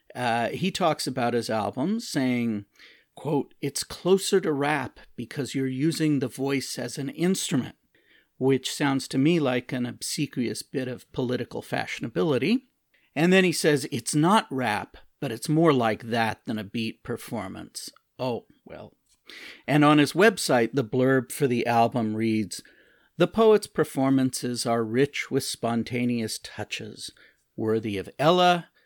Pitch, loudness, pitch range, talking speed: 135 Hz, -25 LUFS, 120-155 Hz, 145 wpm